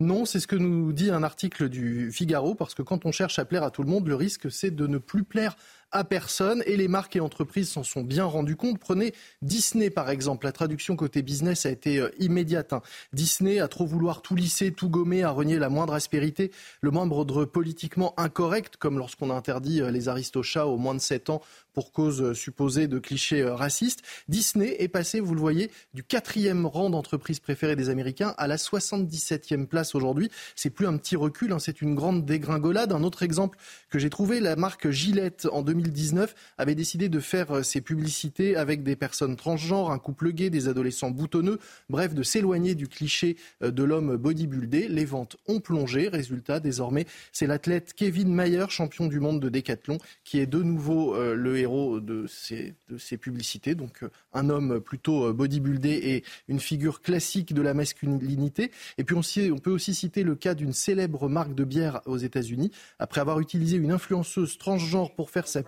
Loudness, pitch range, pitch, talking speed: -27 LUFS, 140-185 Hz, 155 Hz, 195 wpm